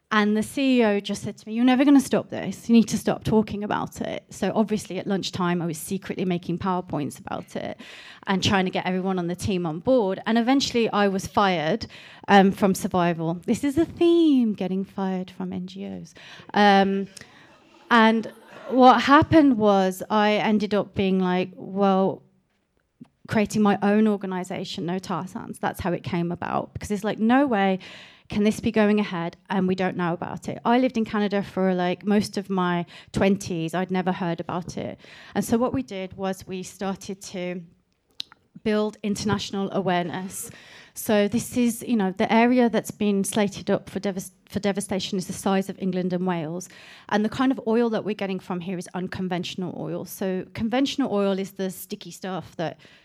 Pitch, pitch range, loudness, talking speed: 195 Hz, 185-215 Hz, -24 LUFS, 190 wpm